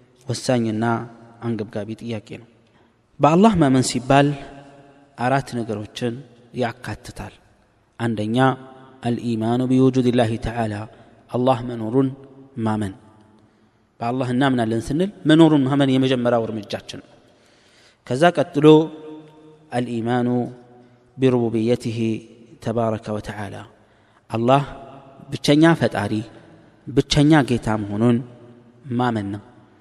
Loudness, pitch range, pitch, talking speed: -20 LUFS, 110-135 Hz, 120 Hz, 90 wpm